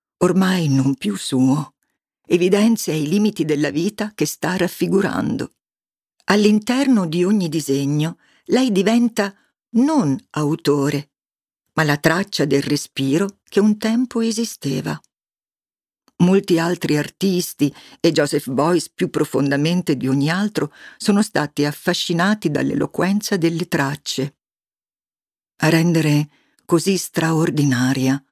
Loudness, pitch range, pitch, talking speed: -19 LUFS, 145-205 Hz, 170 Hz, 105 wpm